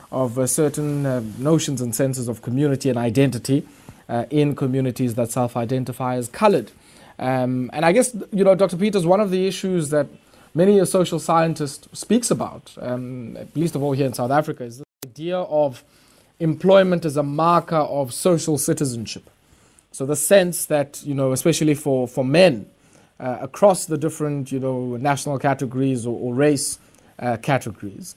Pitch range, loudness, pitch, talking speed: 130-165 Hz, -20 LUFS, 145 Hz, 170 wpm